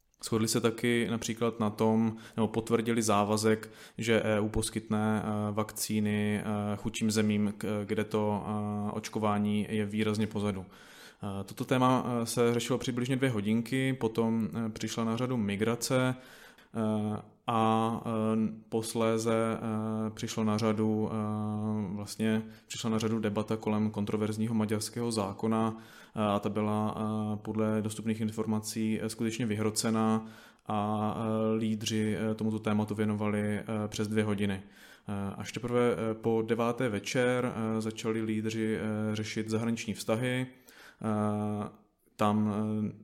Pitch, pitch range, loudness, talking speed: 110 Hz, 105-115 Hz, -31 LUFS, 105 wpm